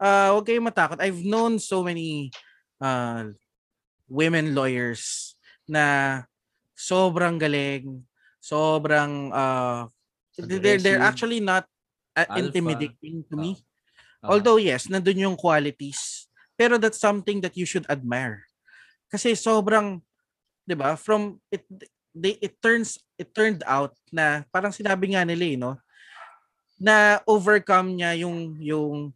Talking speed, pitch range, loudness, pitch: 120 wpm, 145-205 Hz, -23 LUFS, 175 Hz